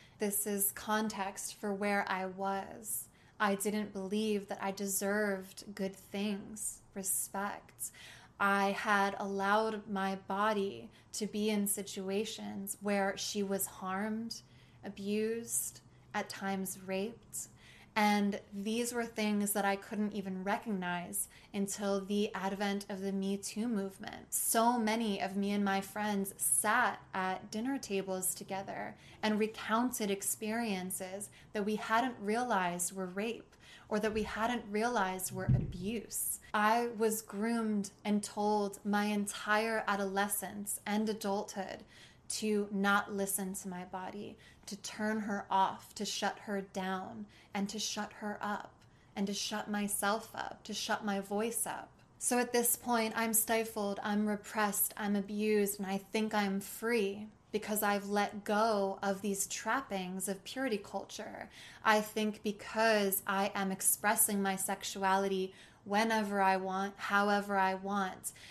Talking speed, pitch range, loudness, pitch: 135 wpm, 195-215 Hz, -35 LUFS, 205 Hz